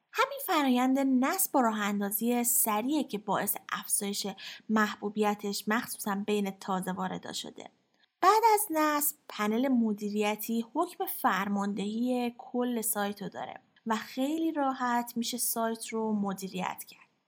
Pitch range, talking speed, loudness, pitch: 205-270 Hz, 120 wpm, -30 LUFS, 230 Hz